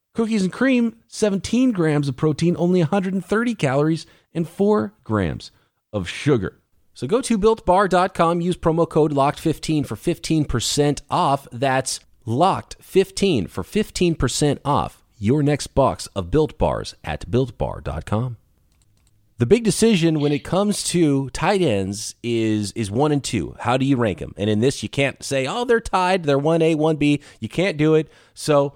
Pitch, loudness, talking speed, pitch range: 155 Hz, -20 LUFS, 170 wpm, 125-180 Hz